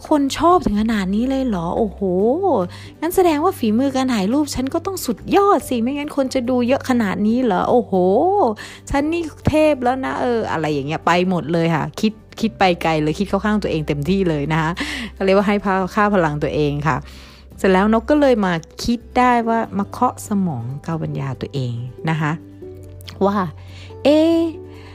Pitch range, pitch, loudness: 160-260 Hz, 205 Hz, -18 LUFS